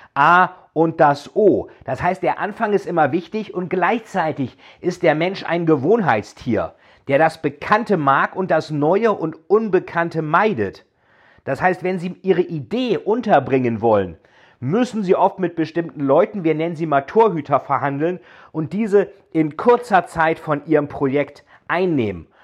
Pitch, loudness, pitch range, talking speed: 165 Hz, -19 LUFS, 145-185 Hz, 150 wpm